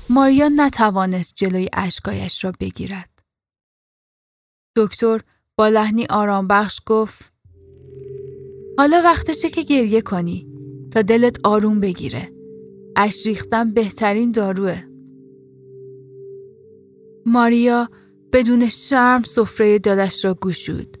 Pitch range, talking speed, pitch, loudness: 175-235 Hz, 90 wpm, 210 Hz, -17 LUFS